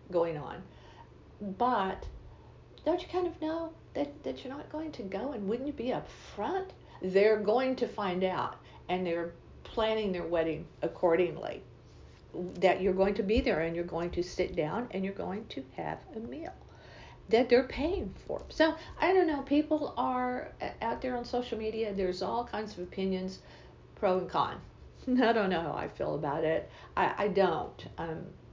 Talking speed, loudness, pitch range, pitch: 180 wpm, -32 LUFS, 185-255 Hz, 215 Hz